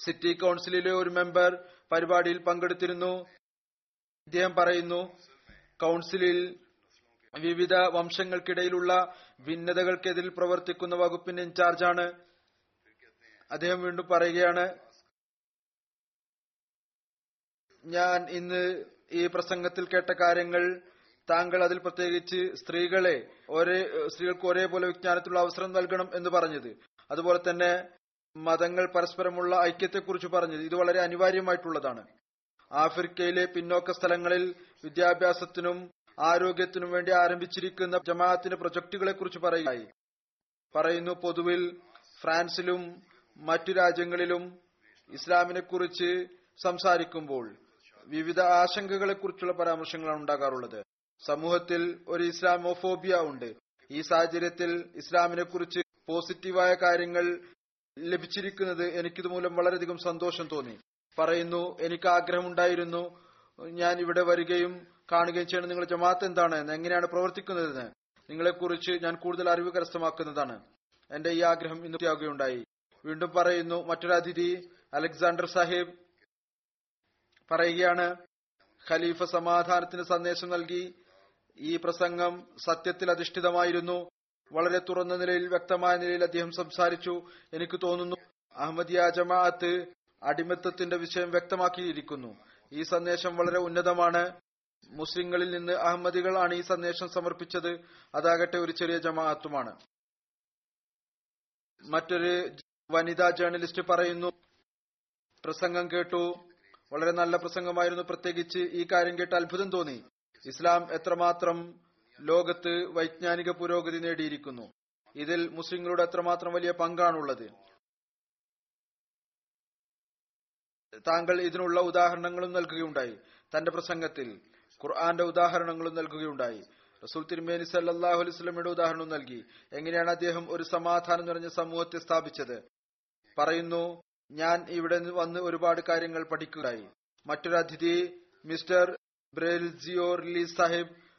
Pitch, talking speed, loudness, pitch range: 175 Hz, 90 wpm, -29 LUFS, 170-180 Hz